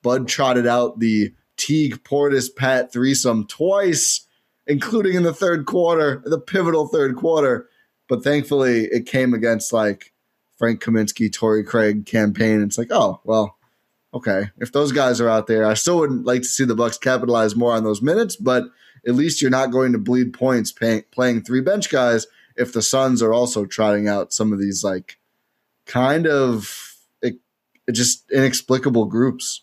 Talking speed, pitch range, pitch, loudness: 175 wpm, 110-135 Hz, 125 Hz, -19 LUFS